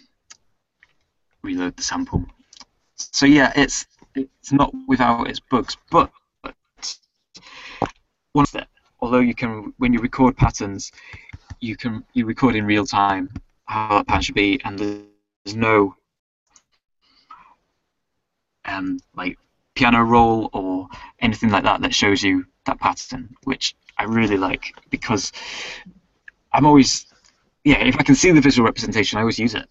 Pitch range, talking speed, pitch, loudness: 105-135 Hz, 140 wpm, 120 Hz, -19 LUFS